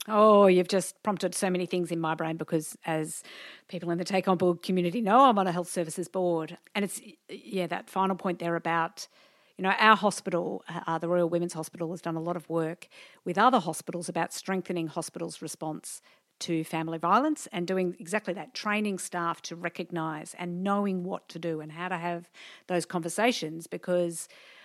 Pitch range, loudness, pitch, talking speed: 165-190 Hz, -29 LUFS, 175 Hz, 190 wpm